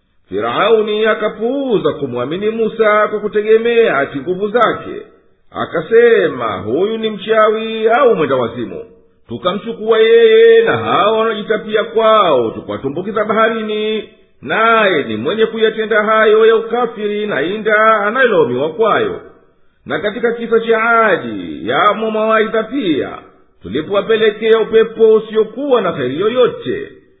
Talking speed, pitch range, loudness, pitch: 105 wpm, 210-230 Hz, -13 LUFS, 220 Hz